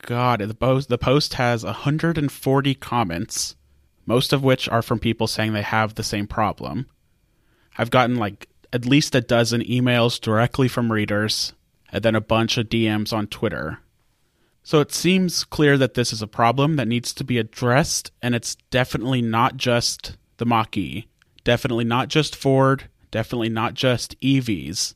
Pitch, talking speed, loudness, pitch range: 120 Hz, 160 wpm, -21 LUFS, 110-130 Hz